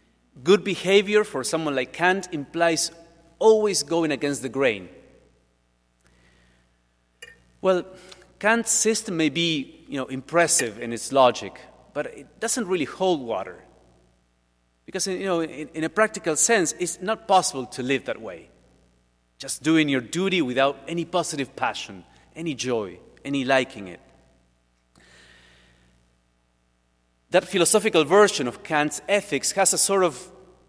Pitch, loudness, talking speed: 145 Hz, -23 LUFS, 130 wpm